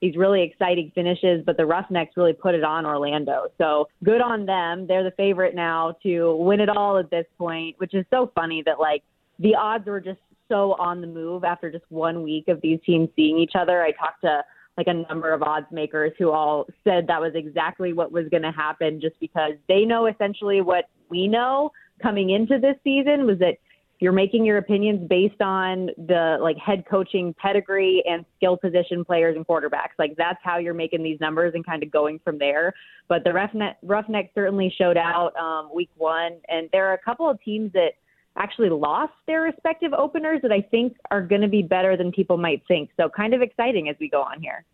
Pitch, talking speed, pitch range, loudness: 180 Hz, 215 wpm, 165-200 Hz, -22 LUFS